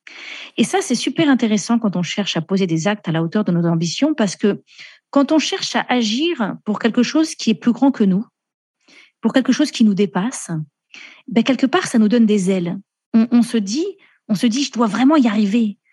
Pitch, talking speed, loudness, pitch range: 230 Hz, 225 wpm, -18 LUFS, 205-270 Hz